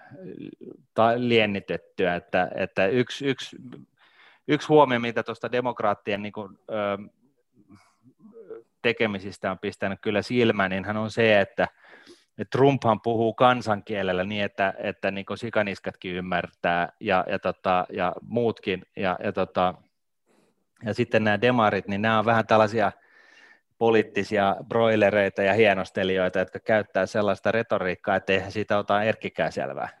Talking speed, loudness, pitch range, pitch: 125 wpm, -24 LUFS, 95-115 Hz, 105 Hz